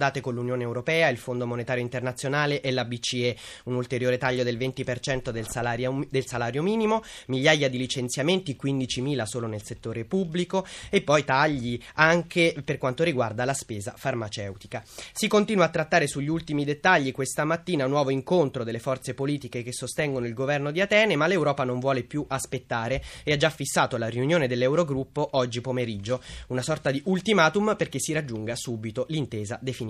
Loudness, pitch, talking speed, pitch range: -26 LUFS, 135 Hz, 170 wpm, 125-155 Hz